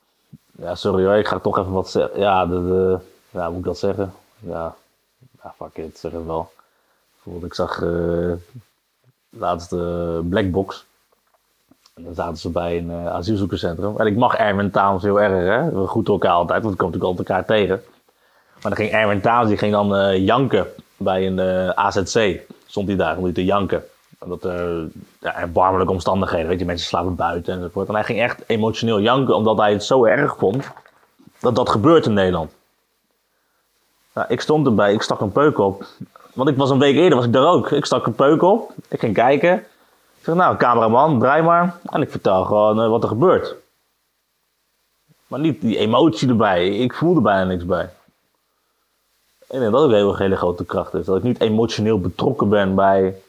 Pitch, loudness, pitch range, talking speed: 95 Hz, -18 LUFS, 90-105 Hz, 195 wpm